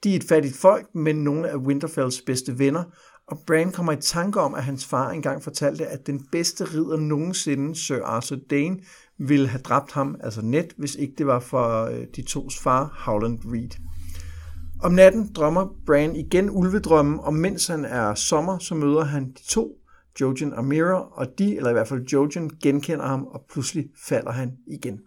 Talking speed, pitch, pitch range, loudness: 190 wpm, 145 Hz, 135-165 Hz, -23 LUFS